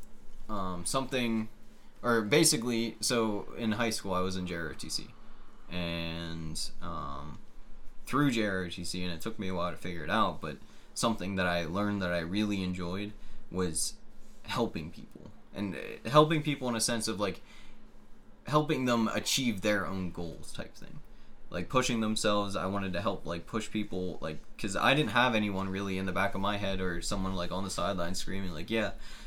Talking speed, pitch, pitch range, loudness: 175 wpm, 100 Hz, 90-110 Hz, -32 LUFS